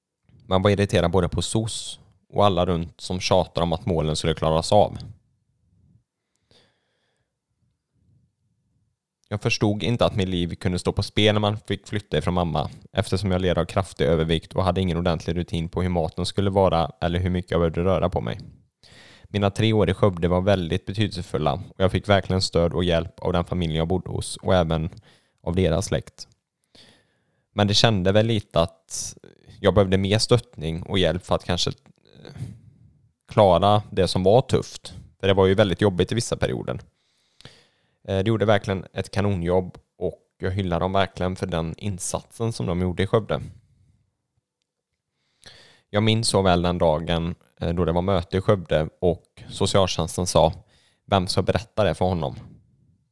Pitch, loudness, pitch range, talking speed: 95 Hz, -23 LUFS, 85-105 Hz, 170 wpm